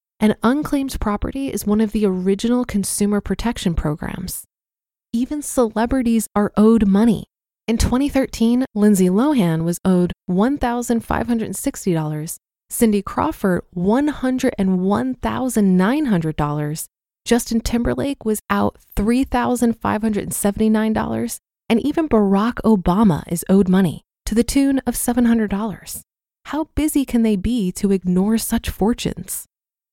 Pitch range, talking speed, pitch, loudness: 195-245 Hz, 105 wpm, 220 Hz, -19 LUFS